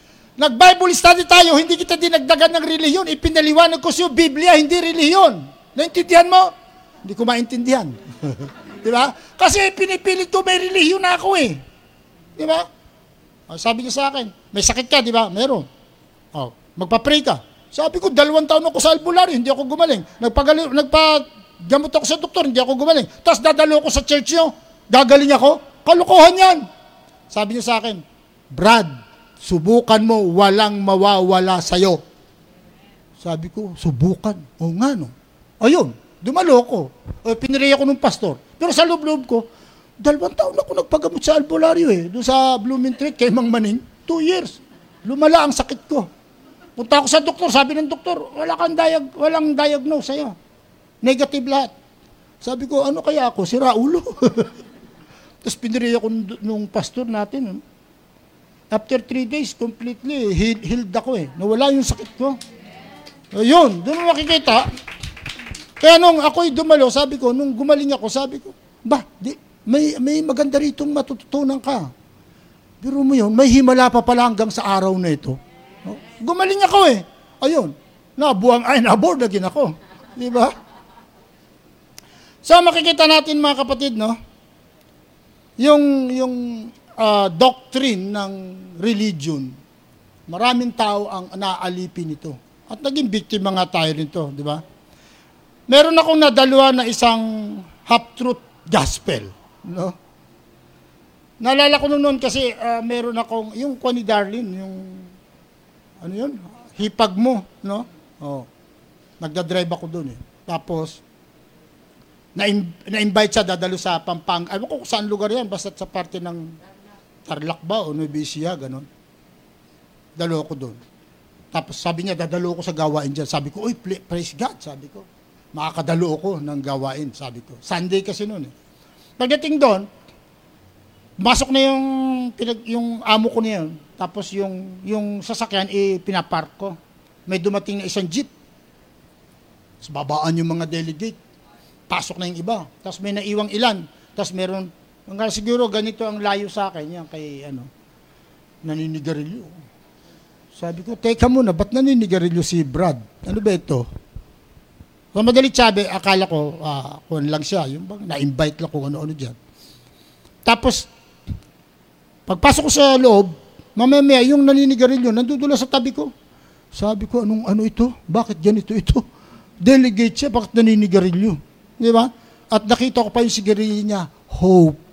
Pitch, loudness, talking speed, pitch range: 225 Hz, -17 LUFS, 150 wpm, 180-275 Hz